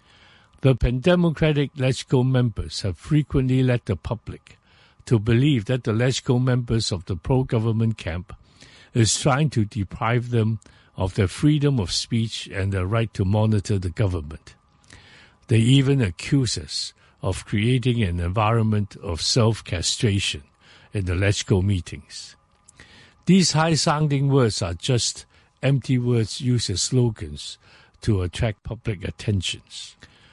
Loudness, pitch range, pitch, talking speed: -22 LUFS, 95-125 Hz, 110 Hz, 125 wpm